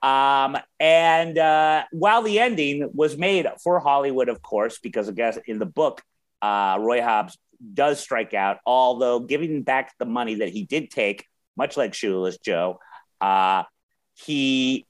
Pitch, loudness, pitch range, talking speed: 140 Hz, -22 LUFS, 125-165 Hz, 155 wpm